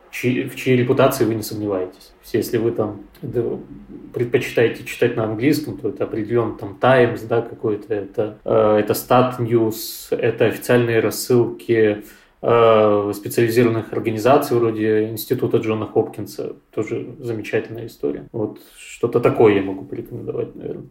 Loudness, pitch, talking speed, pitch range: -19 LUFS, 115 Hz, 135 wpm, 105-125 Hz